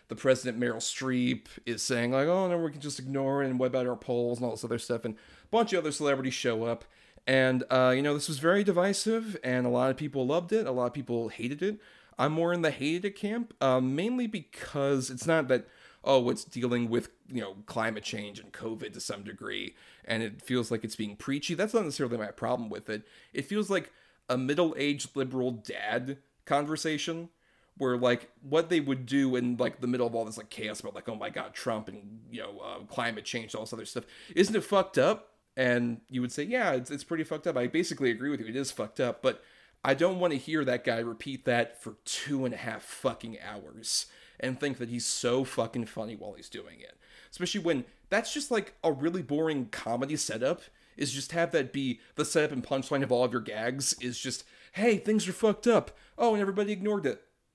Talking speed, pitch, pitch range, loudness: 230 wpm, 135 Hz, 120-165 Hz, -31 LUFS